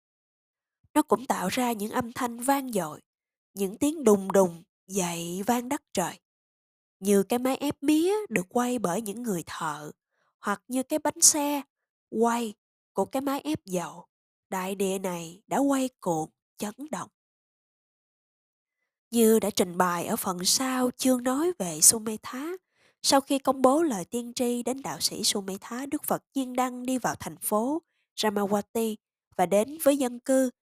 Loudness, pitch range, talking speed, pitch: -27 LUFS, 200-265 Hz, 165 wpm, 235 Hz